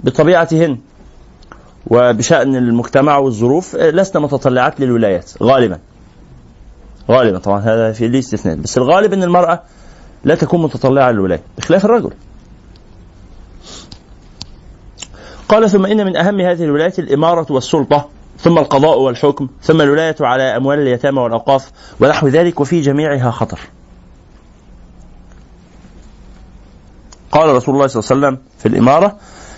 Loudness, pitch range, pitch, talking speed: -13 LUFS, 115-160 Hz, 140 Hz, 110 wpm